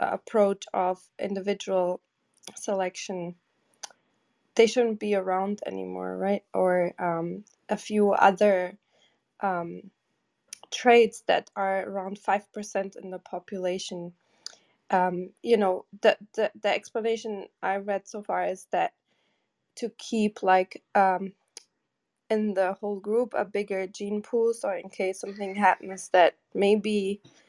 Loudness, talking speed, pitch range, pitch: -27 LUFS, 125 wpm, 185-210 Hz, 195 Hz